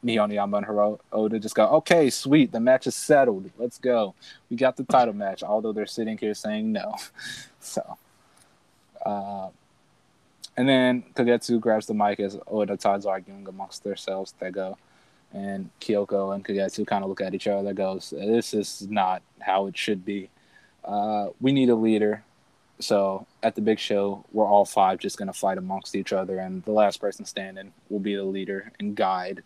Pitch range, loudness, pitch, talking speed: 100-115 Hz, -25 LUFS, 105 Hz, 185 wpm